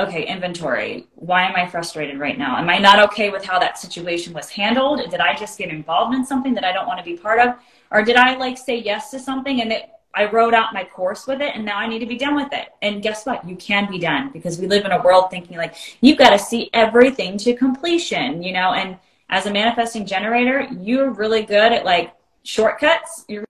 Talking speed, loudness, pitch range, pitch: 245 wpm, -18 LUFS, 185-250 Hz, 210 Hz